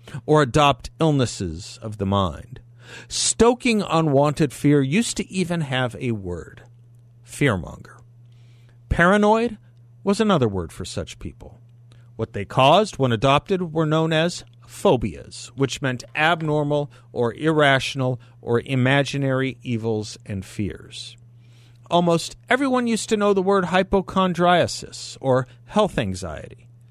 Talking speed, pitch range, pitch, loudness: 120 wpm, 120-160 Hz, 125 Hz, -21 LUFS